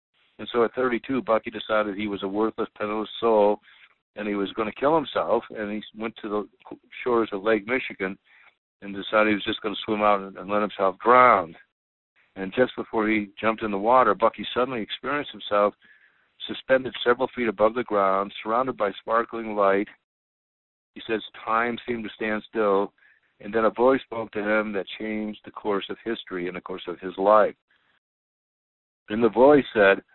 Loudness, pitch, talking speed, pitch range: -24 LUFS, 110 Hz, 185 wpm, 100-115 Hz